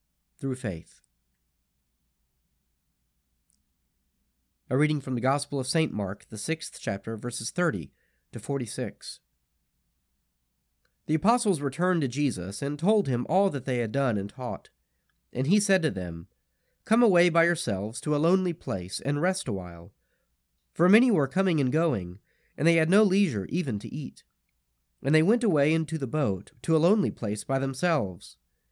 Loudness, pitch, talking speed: -27 LUFS, 130 Hz, 160 wpm